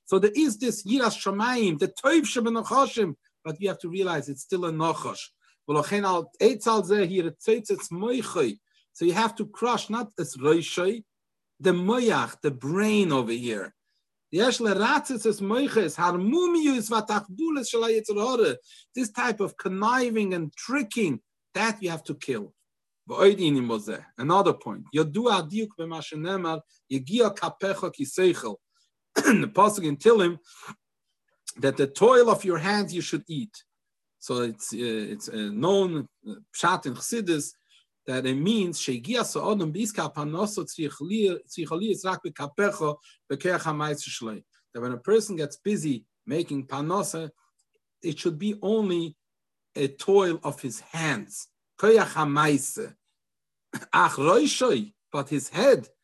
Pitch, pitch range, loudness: 195 Hz, 155-225 Hz, -26 LUFS